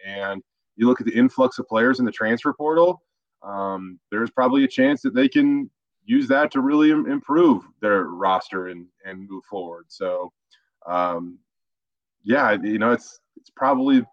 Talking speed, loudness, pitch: 165 wpm, -21 LUFS, 125 Hz